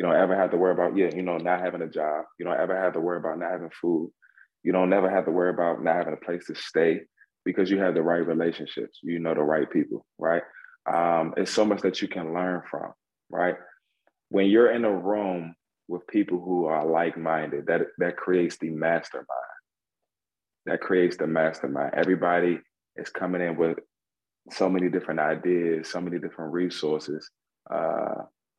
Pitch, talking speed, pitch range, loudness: 85 Hz, 195 wpm, 80-90 Hz, -26 LUFS